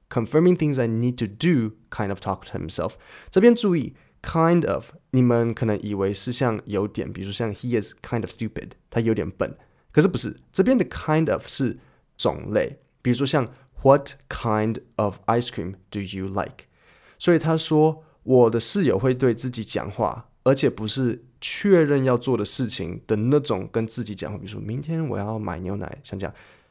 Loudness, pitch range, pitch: -23 LUFS, 105-135 Hz, 115 Hz